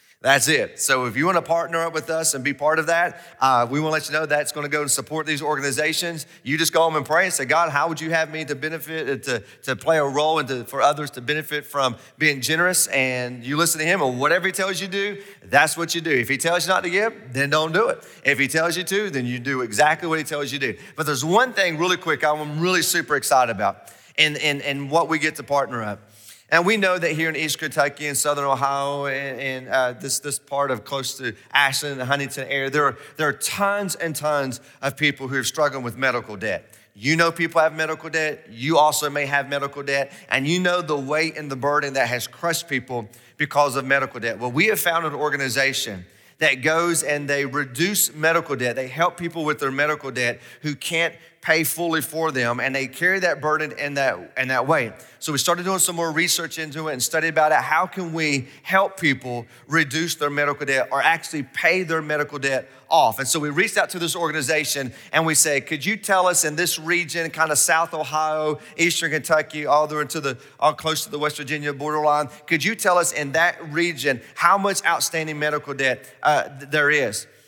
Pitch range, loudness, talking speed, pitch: 140-165 Hz, -21 LUFS, 240 wpm, 150 Hz